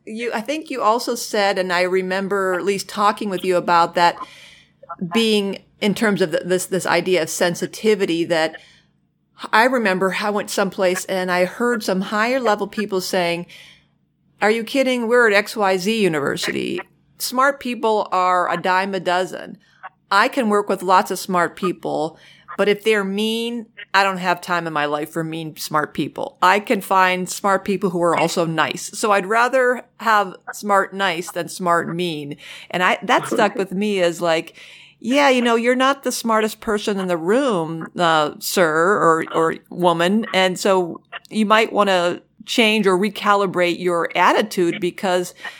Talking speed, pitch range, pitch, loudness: 170 wpm, 175-215 Hz, 190 Hz, -19 LUFS